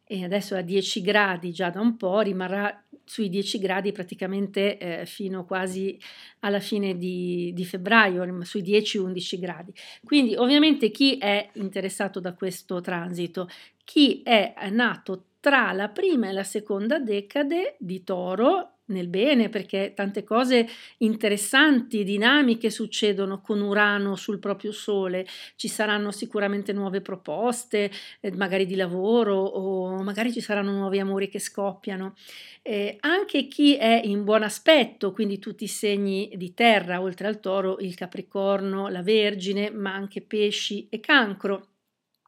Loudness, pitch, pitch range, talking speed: -24 LUFS, 205 Hz, 195-220 Hz, 145 wpm